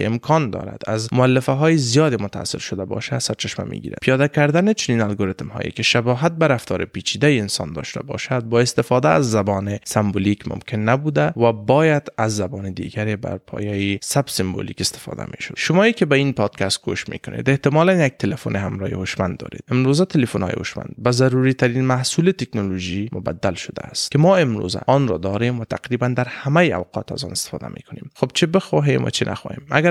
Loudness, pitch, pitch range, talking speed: -20 LUFS, 125 Hz, 100-145 Hz, 190 wpm